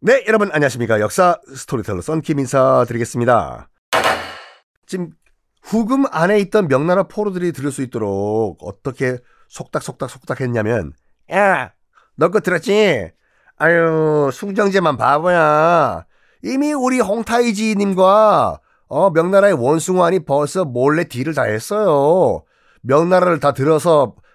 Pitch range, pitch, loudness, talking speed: 135-200 Hz, 165 Hz, -16 LUFS, 275 characters per minute